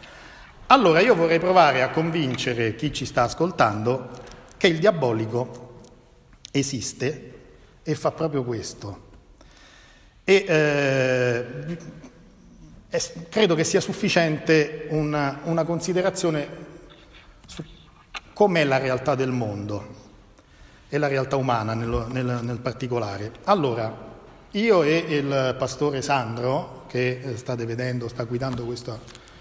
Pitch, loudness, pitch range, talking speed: 130 Hz, -23 LUFS, 120-155 Hz, 110 wpm